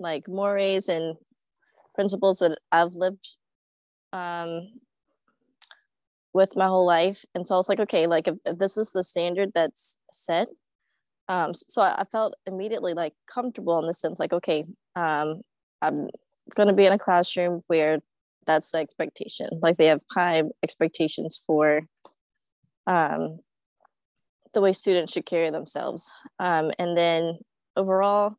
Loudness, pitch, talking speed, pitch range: -25 LUFS, 175 Hz, 145 wpm, 165-195 Hz